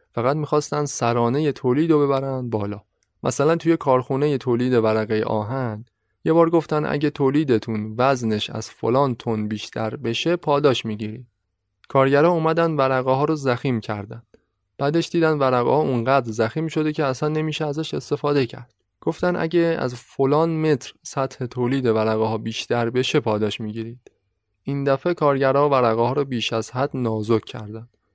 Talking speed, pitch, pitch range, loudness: 145 wpm, 130 Hz, 110-150 Hz, -21 LUFS